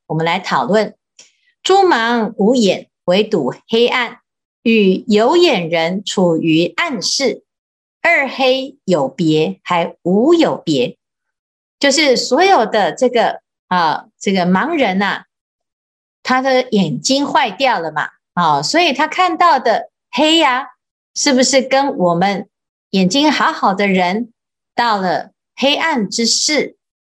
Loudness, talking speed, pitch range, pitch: -14 LUFS, 180 characters per minute, 190-280 Hz, 235 Hz